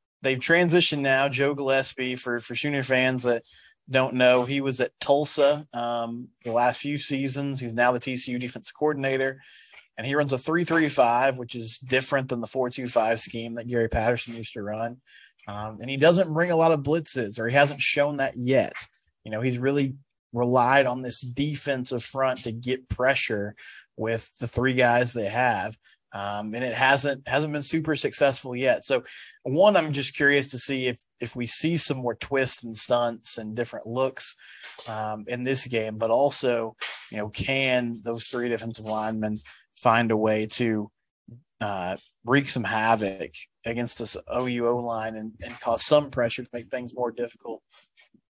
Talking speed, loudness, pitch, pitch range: 175 wpm, -24 LUFS, 125 Hz, 115-135 Hz